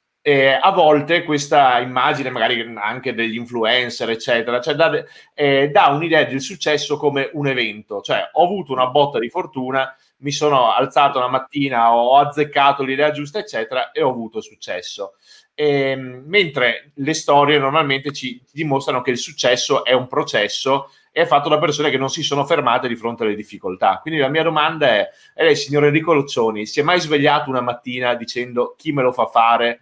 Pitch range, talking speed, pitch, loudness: 125-150 Hz, 180 wpm, 140 Hz, -17 LUFS